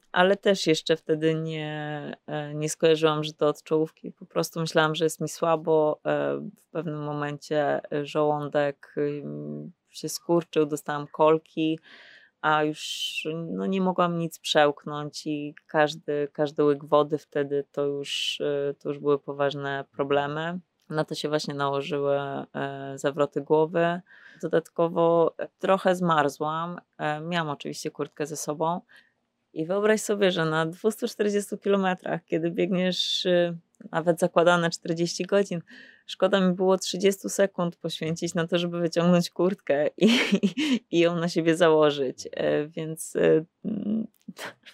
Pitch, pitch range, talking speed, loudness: 160 Hz, 150-175 Hz, 130 wpm, -26 LUFS